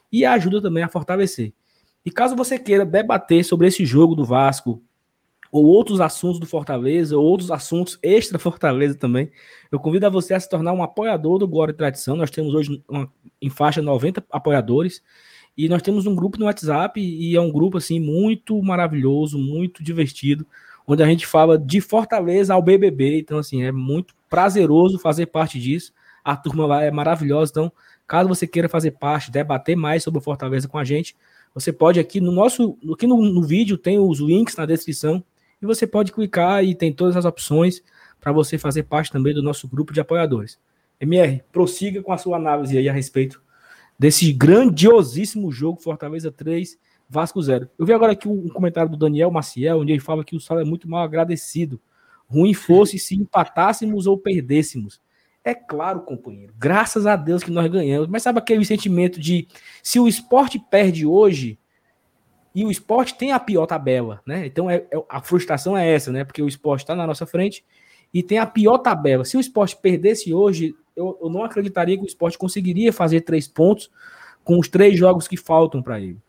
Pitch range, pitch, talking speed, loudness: 150-190 Hz, 165 Hz, 190 wpm, -19 LUFS